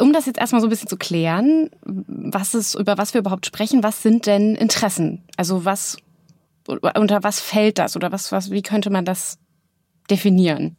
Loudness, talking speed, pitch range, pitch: -19 LUFS, 190 wpm, 185-220 Hz, 200 Hz